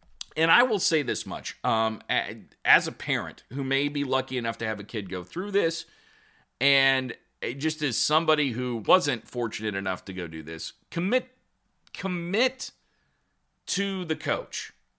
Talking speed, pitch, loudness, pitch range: 155 wpm, 135 Hz, -27 LUFS, 110-160 Hz